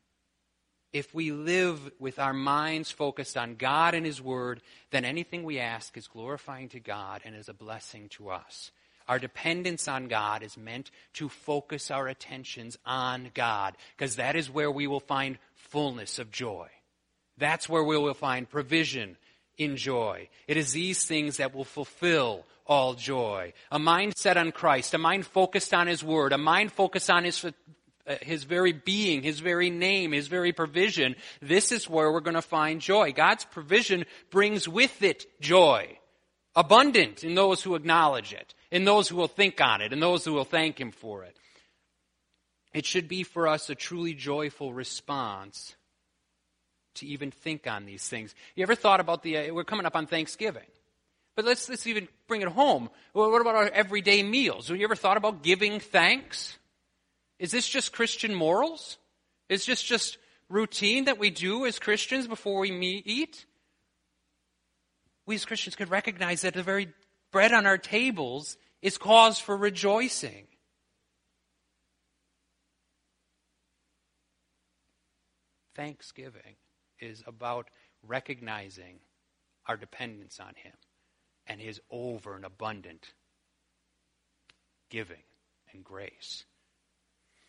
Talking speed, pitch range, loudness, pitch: 150 wpm, 125-195 Hz, -27 LUFS, 155 Hz